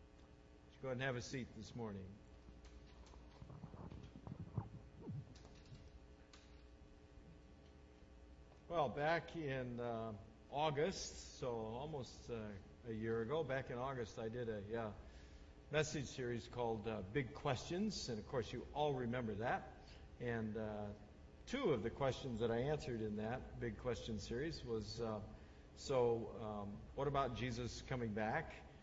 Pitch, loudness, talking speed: 110 Hz, -44 LUFS, 130 wpm